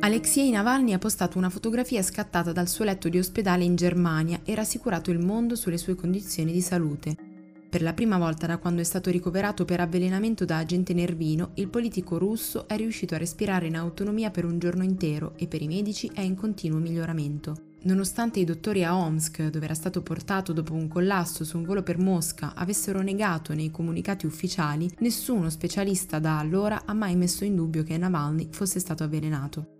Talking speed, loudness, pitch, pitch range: 190 wpm, -27 LUFS, 180 Hz, 165-195 Hz